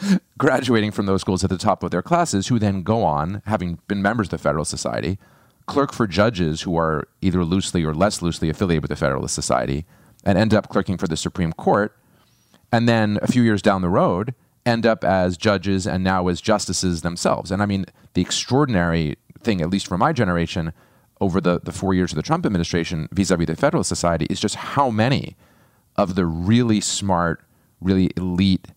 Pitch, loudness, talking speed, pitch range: 95 Hz, -21 LUFS, 200 wpm, 85-105 Hz